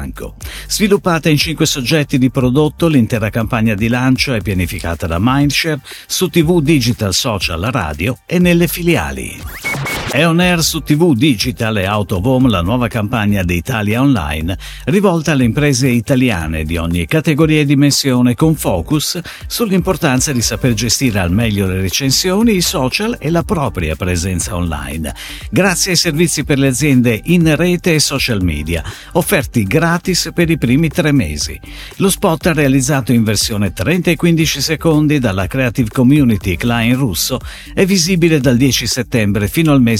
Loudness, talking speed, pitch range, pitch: -14 LUFS, 155 wpm, 110-165 Hz, 135 Hz